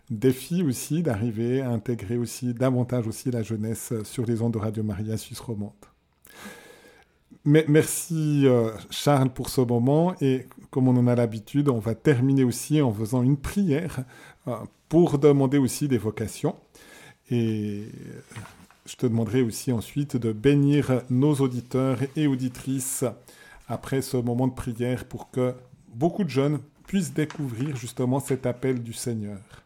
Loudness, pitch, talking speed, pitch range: -25 LUFS, 130 Hz, 150 wpm, 120-140 Hz